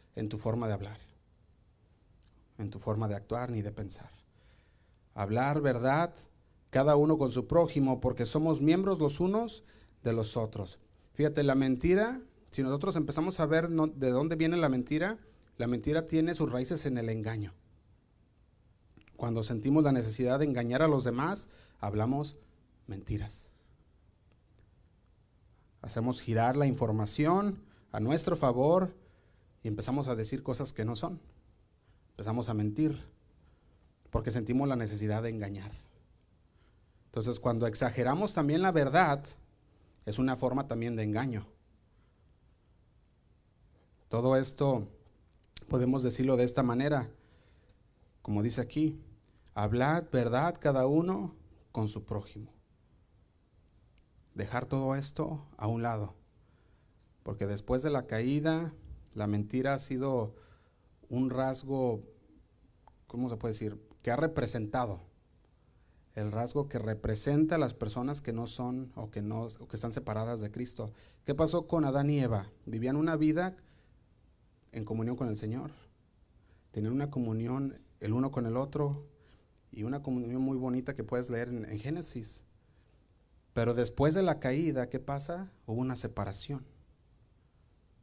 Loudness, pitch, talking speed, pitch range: -32 LUFS, 120 Hz, 135 wpm, 105-140 Hz